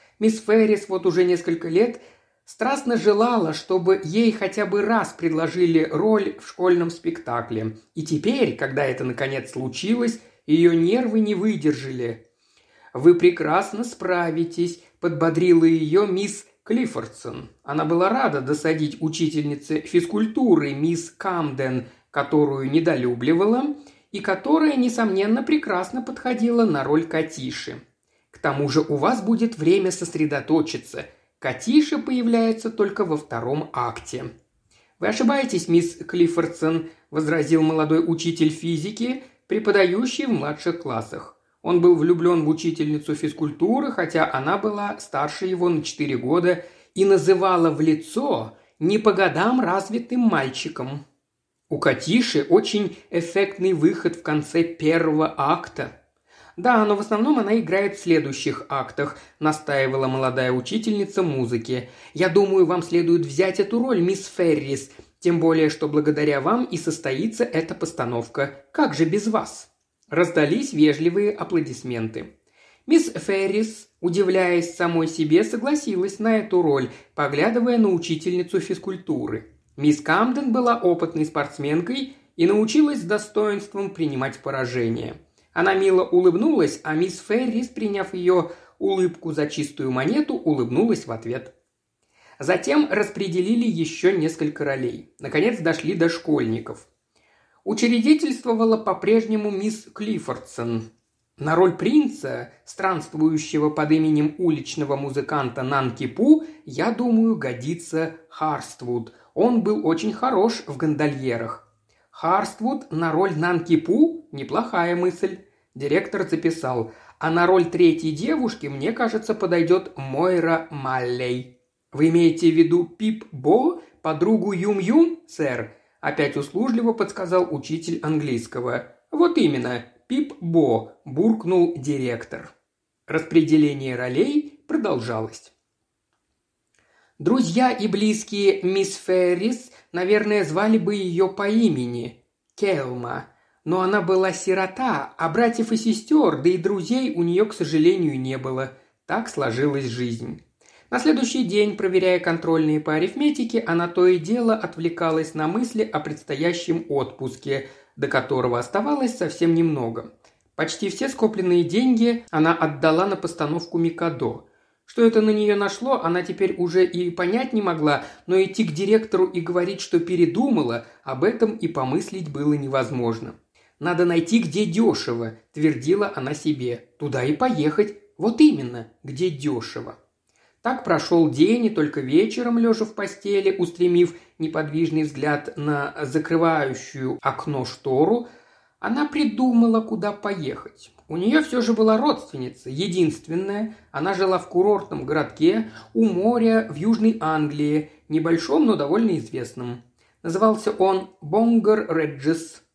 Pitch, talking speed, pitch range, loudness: 175 Hz, 120 wpm, 155-215 Hz, -22 LUFS